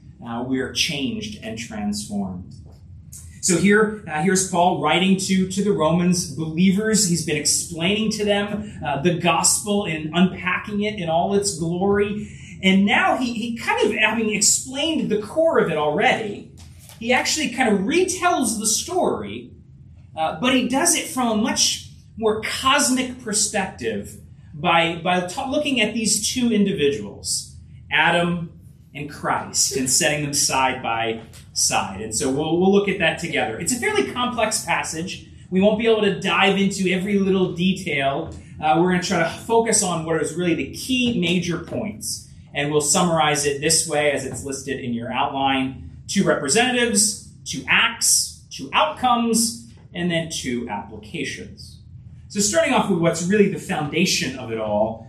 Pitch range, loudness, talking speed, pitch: 150-215 Hz, -20 LUFS, 165 wpm, 180 Hz